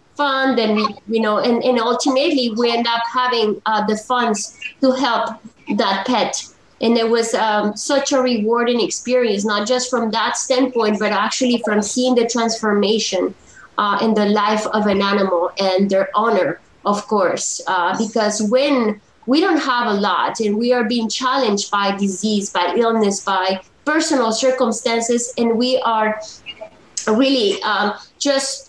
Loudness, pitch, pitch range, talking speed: -18 LUFS, 230 Hz, 210-250 Hz, 160 wpm